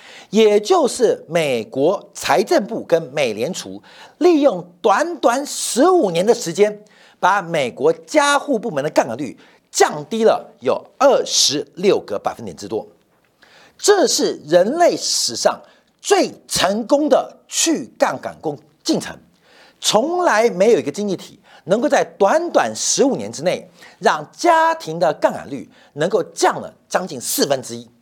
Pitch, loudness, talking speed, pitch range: 285 Hz, -17 LUFS, 210 characters per minute, 210-355 Hz